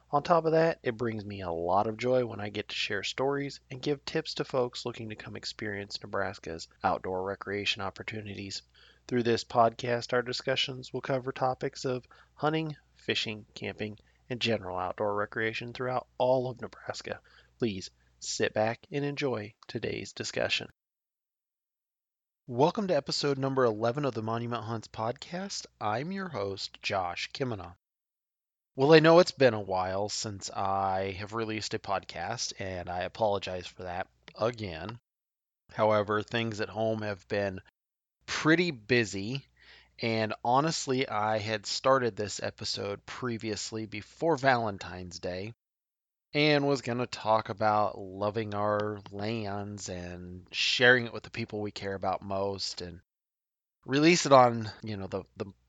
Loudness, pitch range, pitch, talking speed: -30 LUFS, 100-125 Hz, 110 Hz, 150 wpm